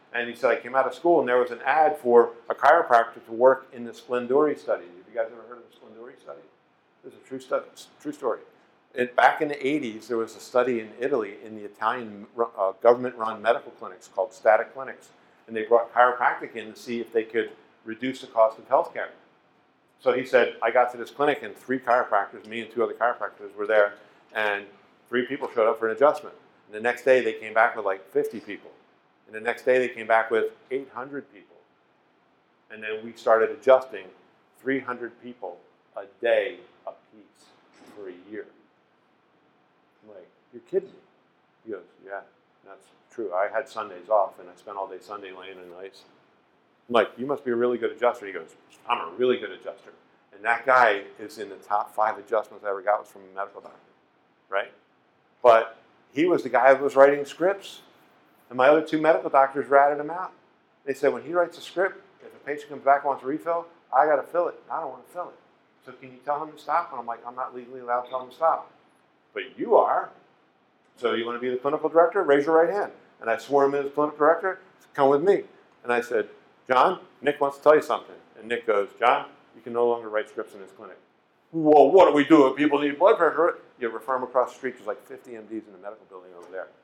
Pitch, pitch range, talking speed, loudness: 125 Hz, 115-145 Hz, 230 wpm, -24 LUFS